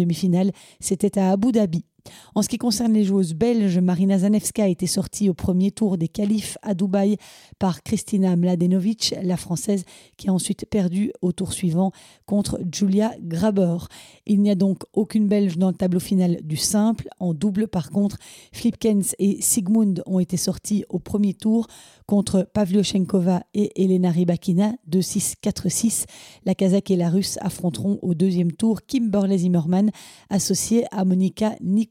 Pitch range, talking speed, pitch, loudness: 180-210 Hz, 160 wpm, 195 Hz, -22 LUFS